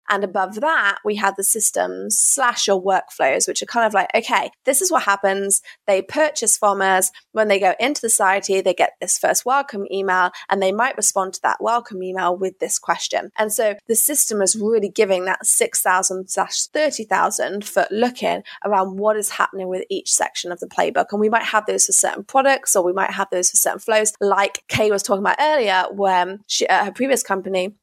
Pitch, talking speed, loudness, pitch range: 200 Hz, 215 wpm, -18 LUFS, 190-225 Hz